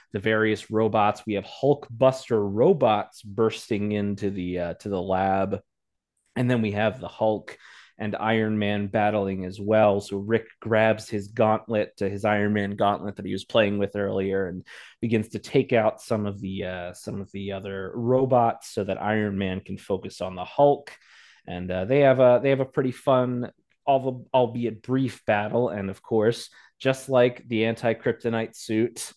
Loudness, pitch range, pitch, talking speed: -25 LUFS, 100-120 Hz, 105 Hz, 180 wpm